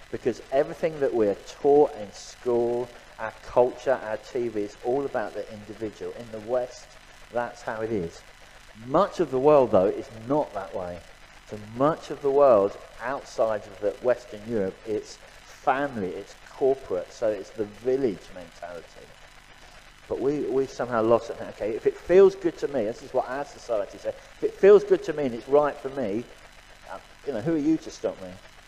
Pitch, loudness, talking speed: 150 Hz, -26 LUFS, 185 wpm